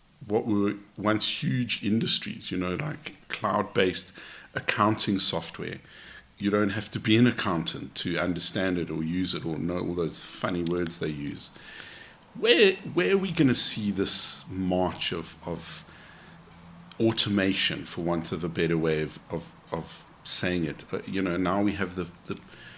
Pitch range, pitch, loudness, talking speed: 85-105 Hz, 95 Hz, -26 LUFS, 165 wpm